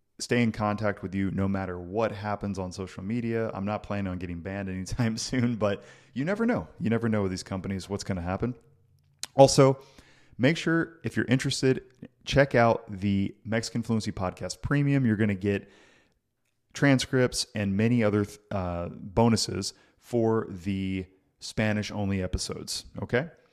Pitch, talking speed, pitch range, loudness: 110 Hz, 160 wpm, 95-120 Hz, -28 LUFS